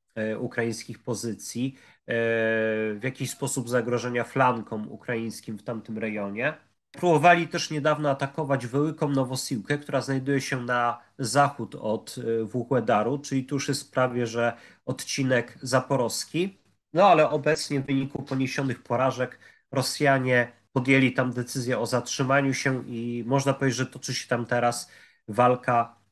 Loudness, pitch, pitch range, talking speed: -26 LUFS, 130 Hz, 120-140 Hz, 125 wpm